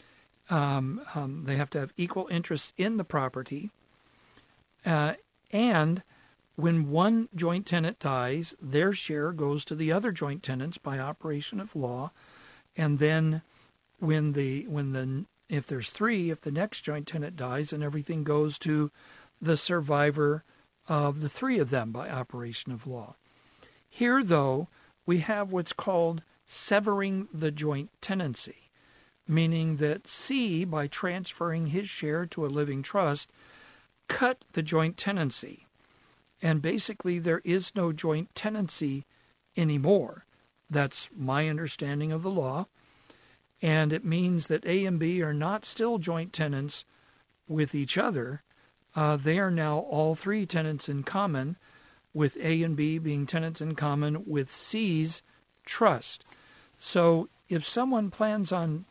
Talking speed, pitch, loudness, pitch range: 140 wpm, 160 Hz, -30 LUFS, 145-180 Hz